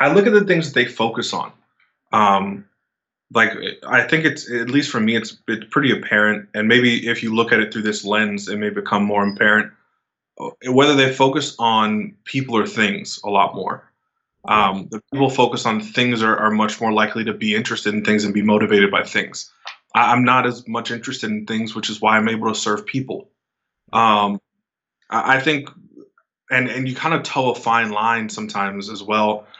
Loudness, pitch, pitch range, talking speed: -18 LUFS, 115 Hz, 105-130 Hz, 205 wpm